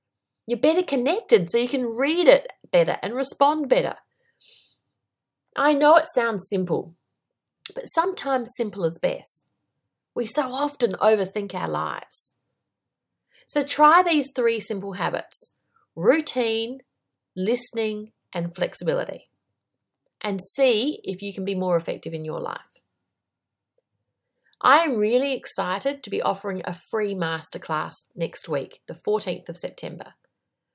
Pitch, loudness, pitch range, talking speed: 235 Hz, -23 LUFS, 195-290 Hz, 125 wpm